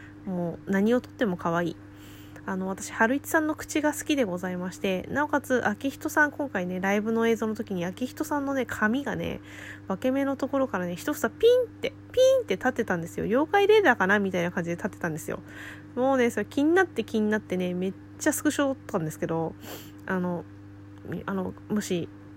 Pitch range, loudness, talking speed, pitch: 175-270 Hz, -27 LUFS, 400 characters per minute, 205 Hz